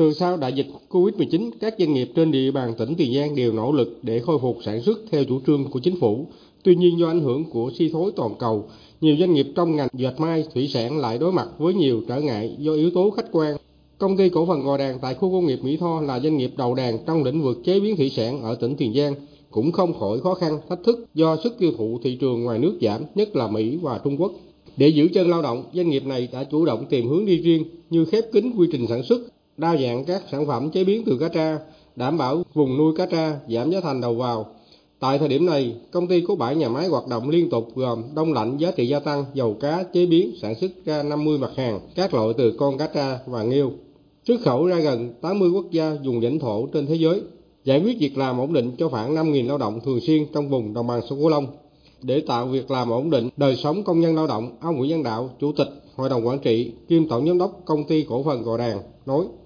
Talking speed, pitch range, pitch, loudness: 260 wpm, 125-165 Hz, 150 Hz, -22 LUFS